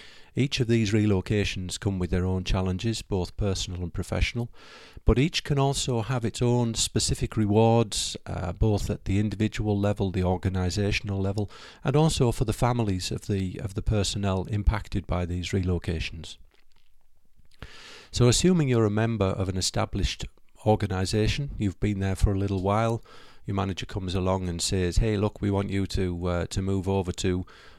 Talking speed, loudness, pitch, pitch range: 170 wpm, -27 LUFS, 100 Hz, 95-115 Hz